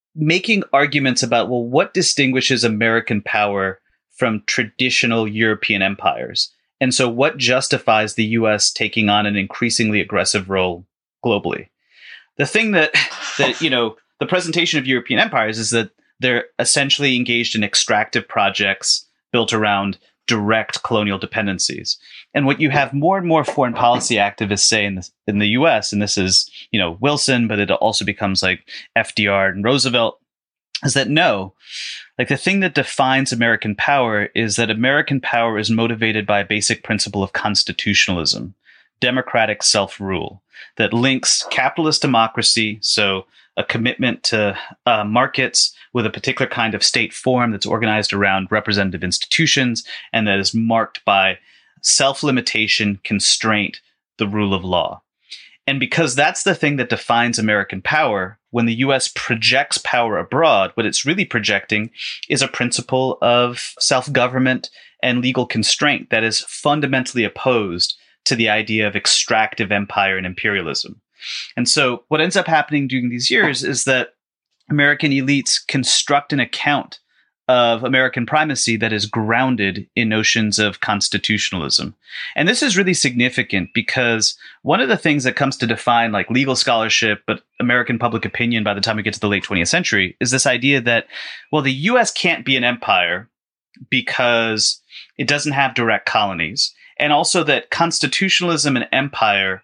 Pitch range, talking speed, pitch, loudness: 105-135 Hz, 155 wpm, 115 Hz, -17 LUFS